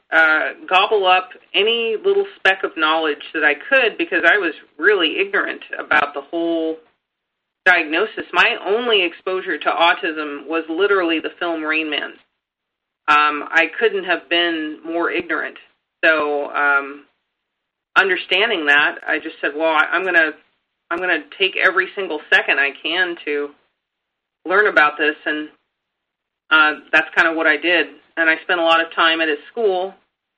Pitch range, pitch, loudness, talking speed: 150-190 Hz, 165 Hz, -17 LUFS, 160 wpm